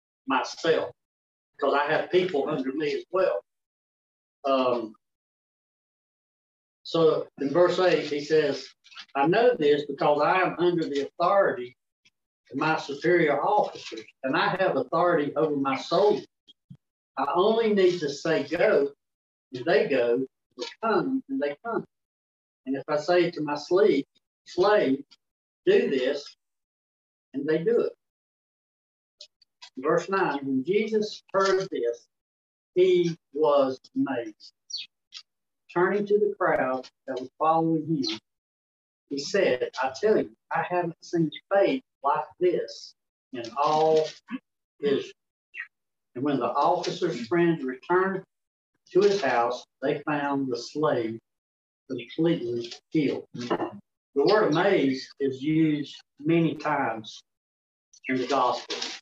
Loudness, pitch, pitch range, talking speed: -26 LUFS, 155 Hz, 135-195 Hz, 120 wpm